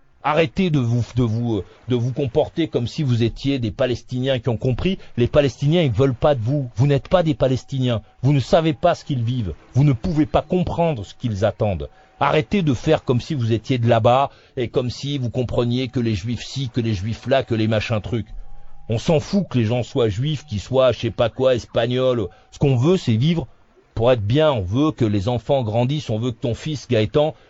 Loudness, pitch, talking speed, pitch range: -20 LUFS, 125 Hz, 230 wpm, 115-145 Hz